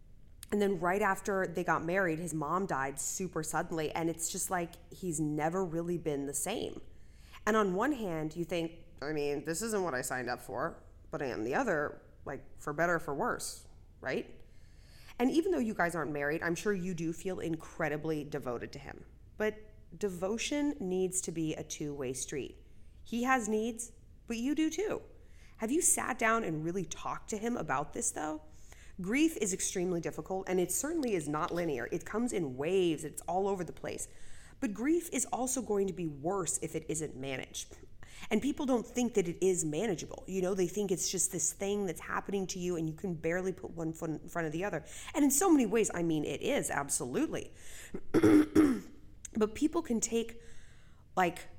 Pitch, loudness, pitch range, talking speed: 185 Hz, -34 LUFS, 160-220 Hz, 200 wpm